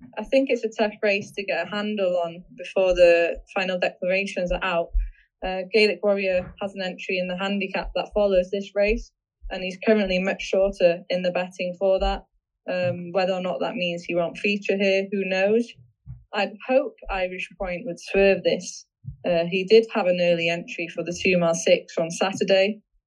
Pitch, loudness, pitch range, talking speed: 190 Hz, -23 LUFS, 180-205 Hz, 185 wpm